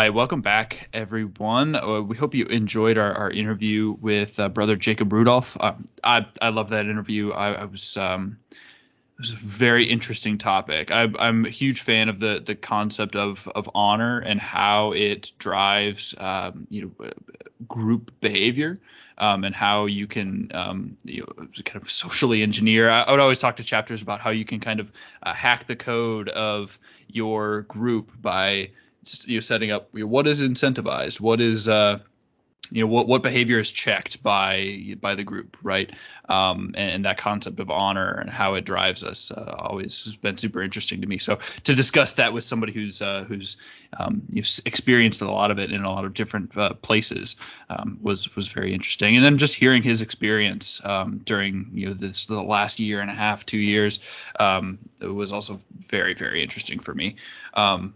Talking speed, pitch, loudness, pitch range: 195 wpm, 105 Hz, -22 LUFS, 100-115 Hz